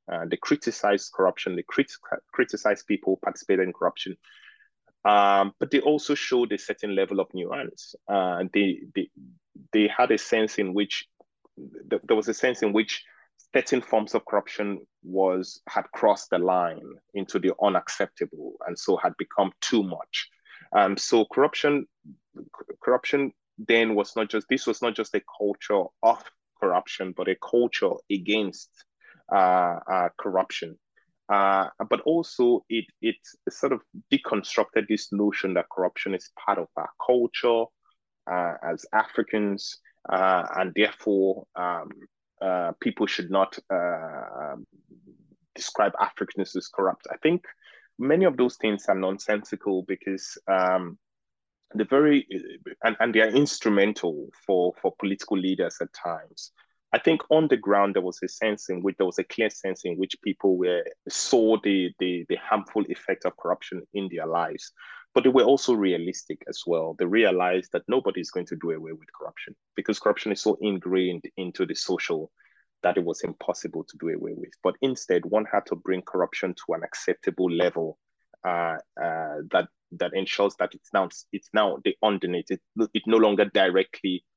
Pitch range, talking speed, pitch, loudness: 95-120 Hz, 165 wpm, 105 Hz, -26 LUFS